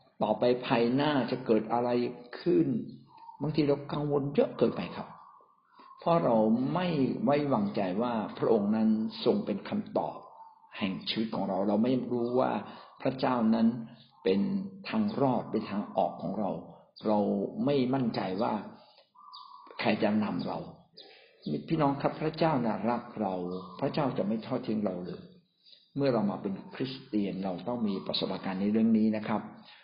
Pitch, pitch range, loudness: 125 Hz, 110-155 Hz, -30 LUFS